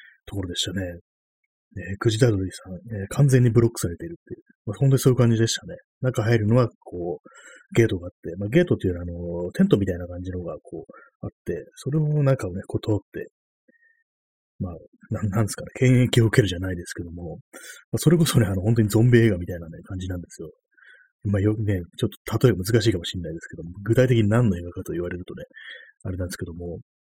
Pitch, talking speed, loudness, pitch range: 105 Hz, 460 characters per minute, -23 LUFS, 90-120 Hz